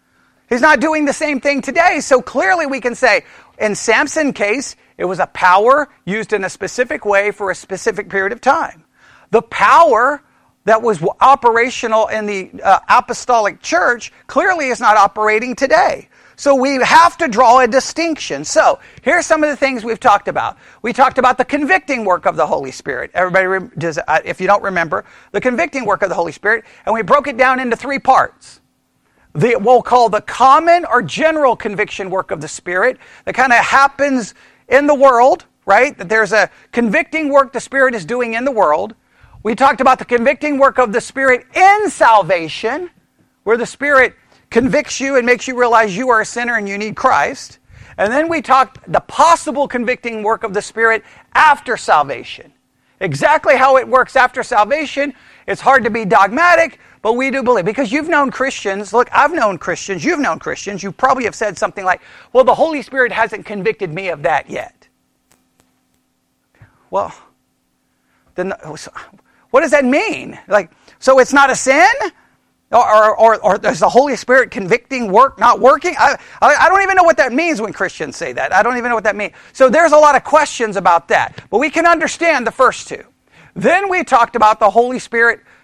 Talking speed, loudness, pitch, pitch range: 195 wpm, -13 LUFS, 250 Hz, 215-280 Hz